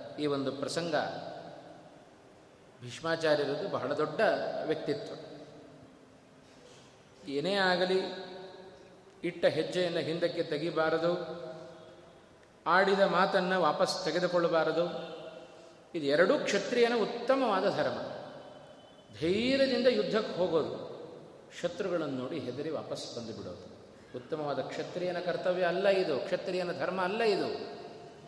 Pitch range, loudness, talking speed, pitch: 160-190 Hz, -31 LUFS, 85 wpm, 170 Hz